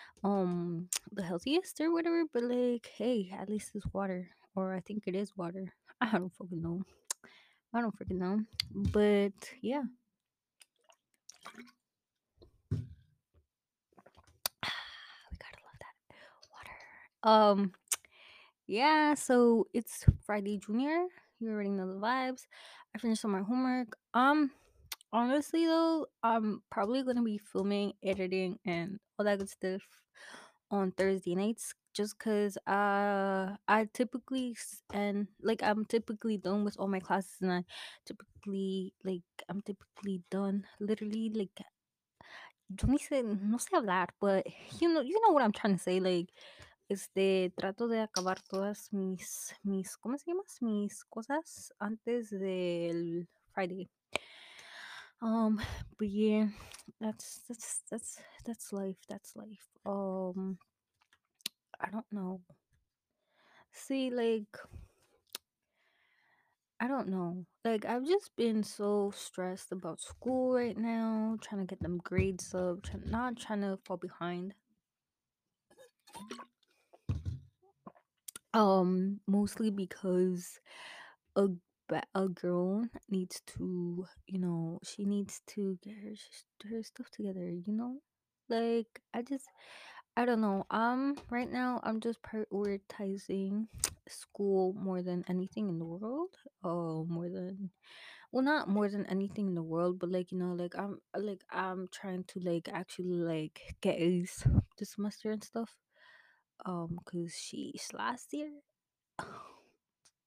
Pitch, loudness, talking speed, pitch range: 205 Hz, -35 LUFS, 130 wpm, 185-230 Hz